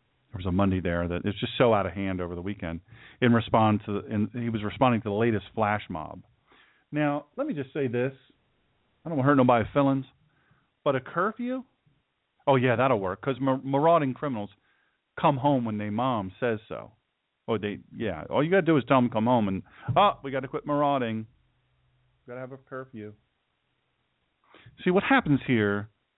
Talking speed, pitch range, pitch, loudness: 200 wpm, 105-140 Hz, 125 Hz, -26 LUFS